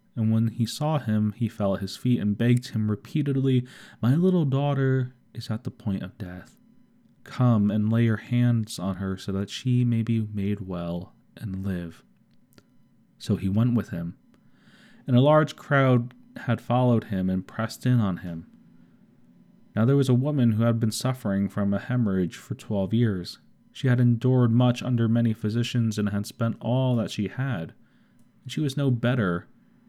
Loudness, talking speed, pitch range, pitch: -25 LUFS, 180 wpm, 105-125 Hz, 115 Hz